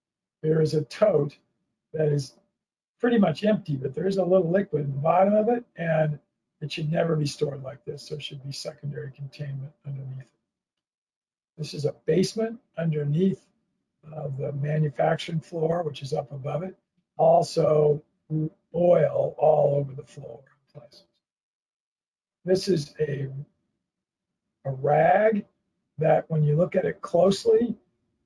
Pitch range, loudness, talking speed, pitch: 145-185 Hz, -25 LUFS, 145 wpm, 155 Hz